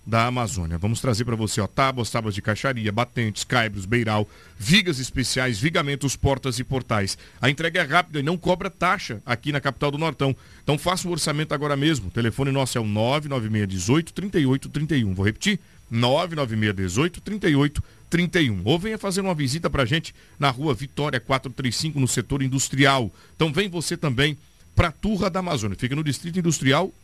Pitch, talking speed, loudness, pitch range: 135 Hz, 170 wpm, -23 LUFS, 115-160 Hz